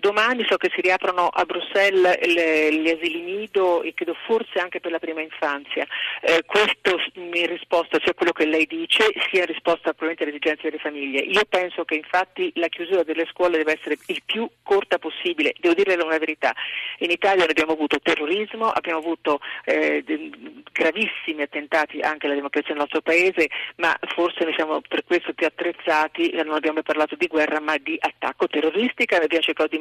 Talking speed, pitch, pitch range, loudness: 180 wpm, 165 Hz, 155-185 Hz, -22 LUFS